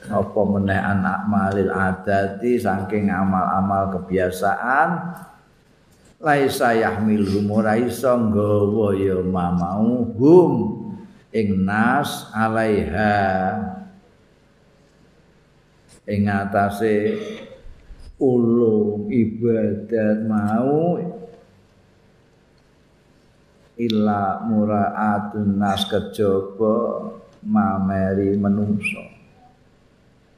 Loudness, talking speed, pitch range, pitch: -20 LUFS, 55 wpm, 100-110 Hz, 105 Hz